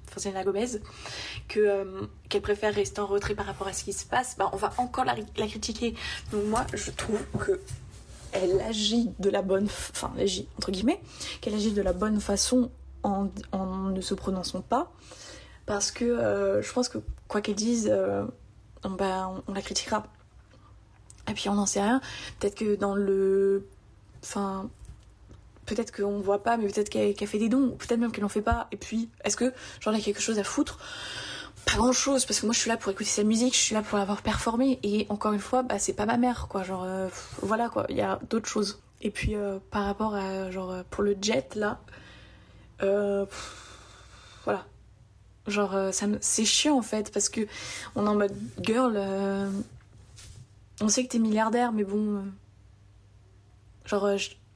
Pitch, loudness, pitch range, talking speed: 205 Hz, -28 LUFS, 190-220 Hz, 205 wpm